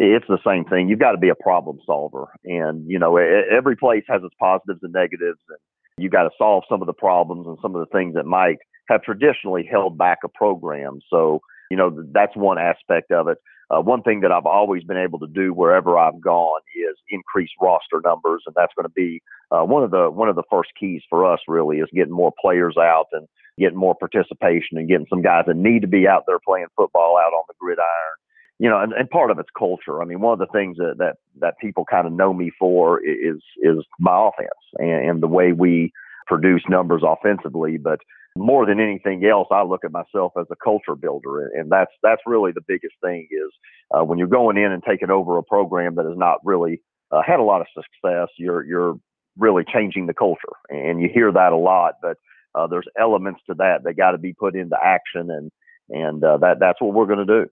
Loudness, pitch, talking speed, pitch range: -19 LUFS, 90 Hz, 230 wpm, 85-105 Hz